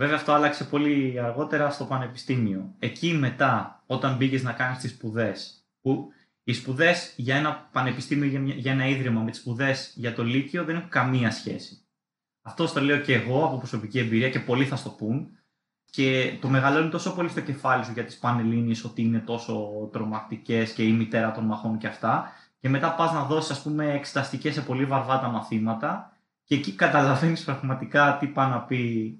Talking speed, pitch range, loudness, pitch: 185 wpm, 115-145 Hz, -26 LUFS, 130 Hz